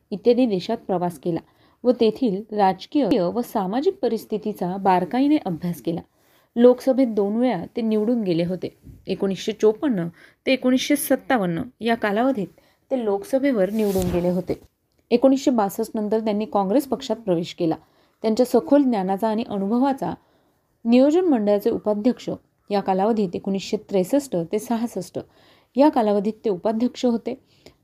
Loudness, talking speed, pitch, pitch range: -22 LUFS, 125 wpm, 220 Hz, 195-250 Hz